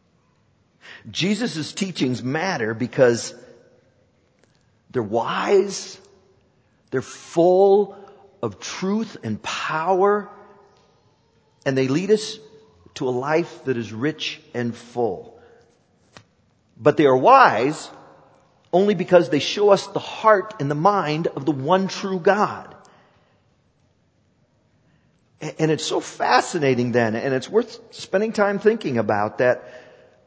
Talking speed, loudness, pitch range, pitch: 110 wpm, -21 LUFS, 130-200 Hz, 165 Hz